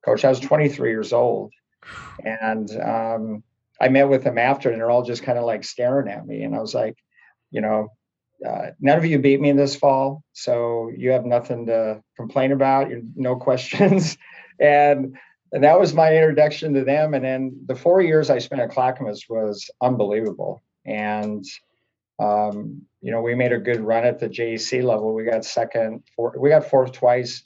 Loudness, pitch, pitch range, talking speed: -20 LUFS, 125 Hz, 115-140 Hz, 195 wpm